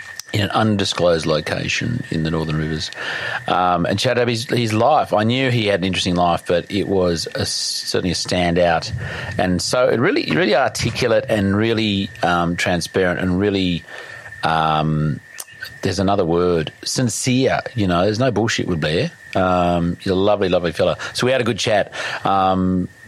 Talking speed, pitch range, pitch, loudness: 165 wpm, 85-105 Hz, 95 Hz, -19 LUFS